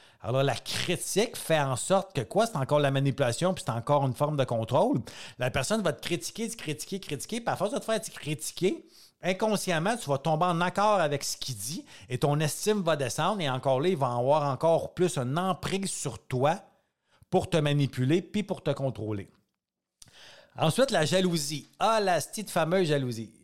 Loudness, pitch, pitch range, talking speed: -28 LUFS, 155 Hz, 135-185 Hz, 200 wpm